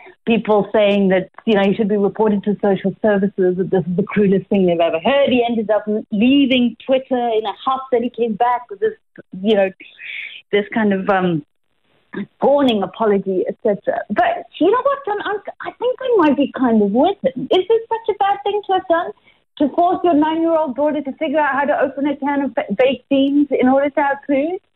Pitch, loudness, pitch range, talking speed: 260 Hz, -17 LUFS, 210-315 Hz, 215 wpm